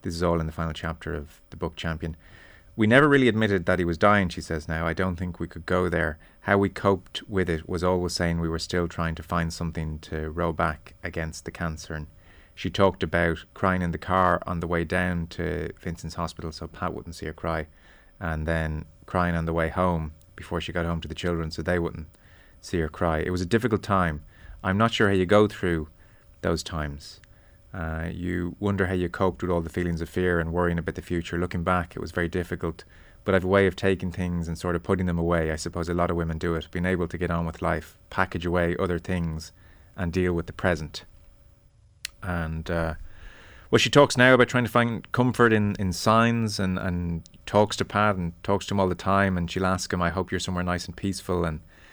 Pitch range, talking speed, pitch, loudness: 85-95 Hz, 235 wpm, 90 Hz, -26 LUFS